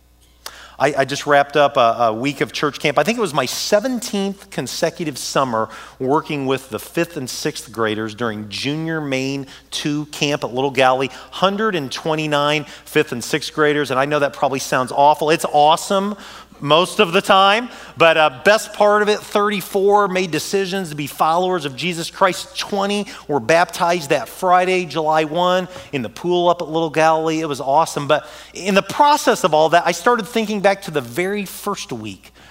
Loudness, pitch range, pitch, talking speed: -18 LUFS, 140-195 Hz, 160 Hz, 180 wpm